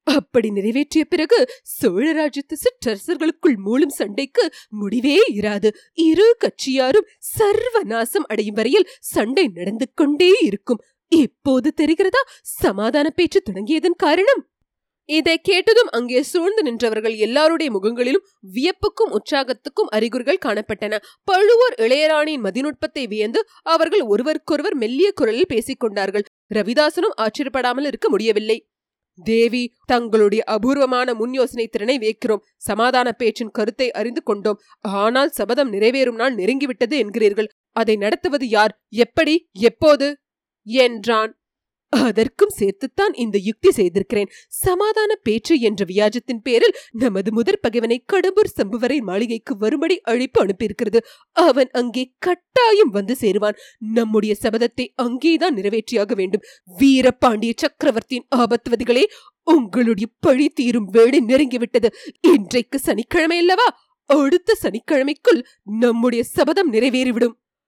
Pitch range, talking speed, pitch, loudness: 225-325 Hz, 100 wpm, 255 Hz, -18 LUFS